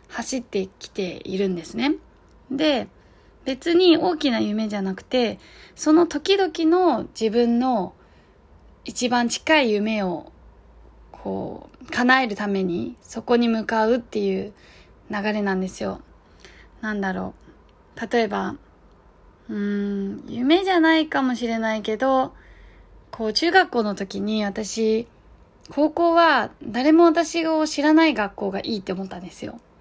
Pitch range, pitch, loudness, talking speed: 205-305 Hz, 235 Hz, -22 LUFS, 240 characters per minute